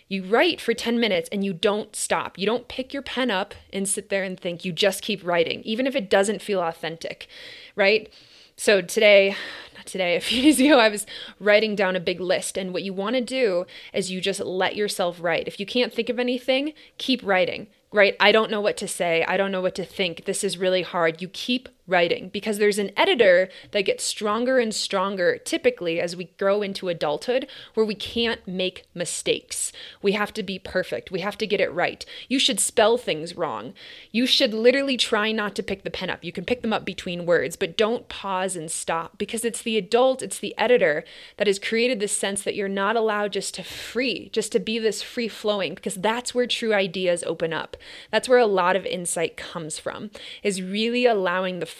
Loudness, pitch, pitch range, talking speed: -23 LUFS, 210 Hz, 190-240 Hz, 220 wpm